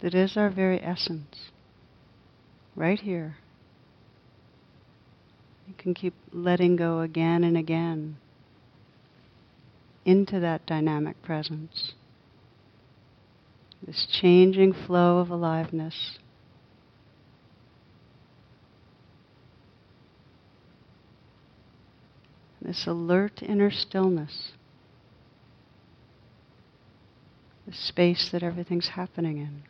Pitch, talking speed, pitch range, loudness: 155 Hz, 70 wpm, 120-175 Hz, -26 LUFS